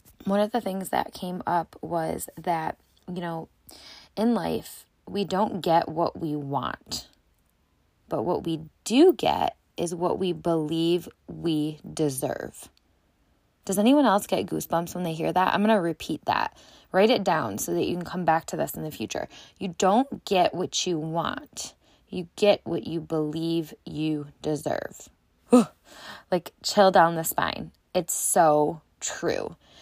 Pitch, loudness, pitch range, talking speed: 170 Hz, -26 LUFS, 155-190 Hz, 160 wpm